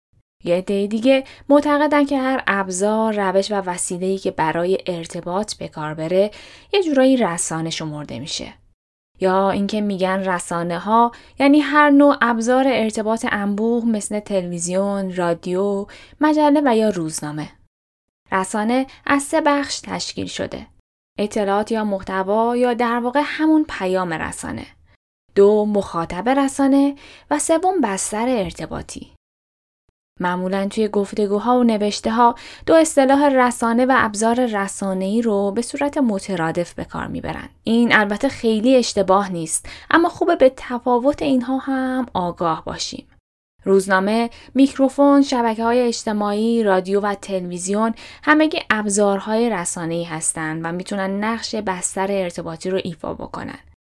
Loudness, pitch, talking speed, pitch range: -19 LUFS, 210 Hz, 125 wpm, 185-255 Hz